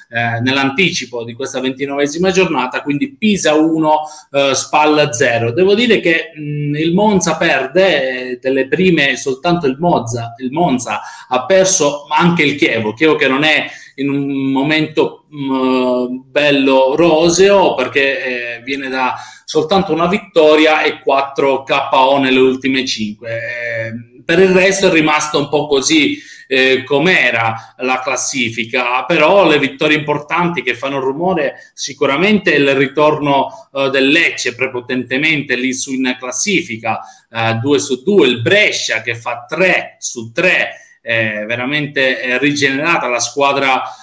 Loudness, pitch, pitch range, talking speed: -13 LUFS, 140 Hz, 130-160 Hz, 130 wpm